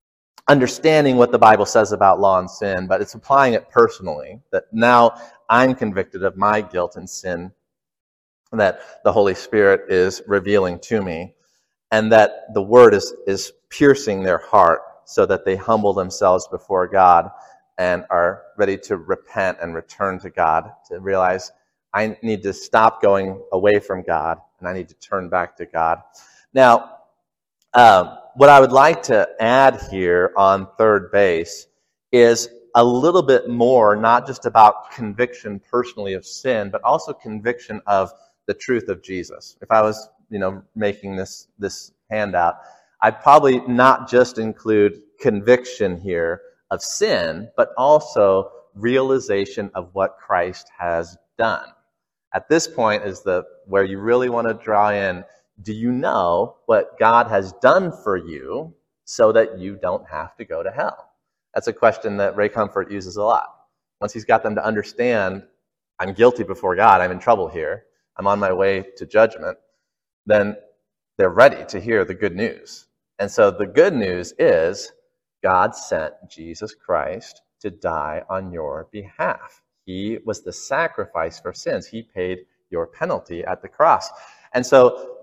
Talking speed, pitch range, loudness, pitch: 160 wpm, 95-130 Hz, -18 LUFS, 110 Hz